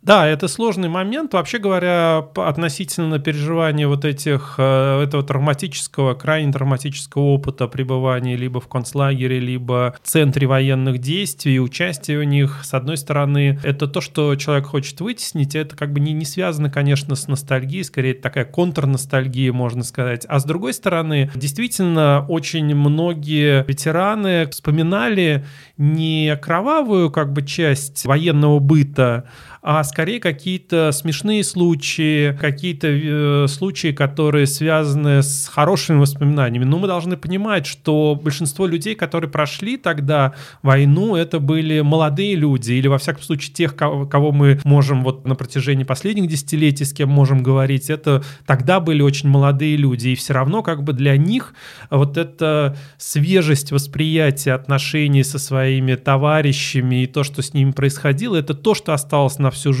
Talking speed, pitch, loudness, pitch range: 150 wpm, 145 Hz, -18 LUFS, 140-160 Hz